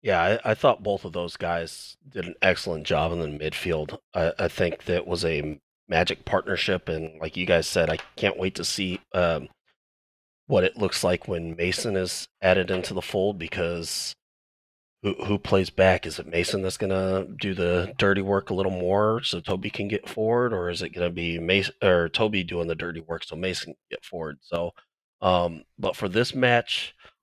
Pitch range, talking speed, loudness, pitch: 85-95 Hz, 200 wpm, -26 LUFS, 90 Hz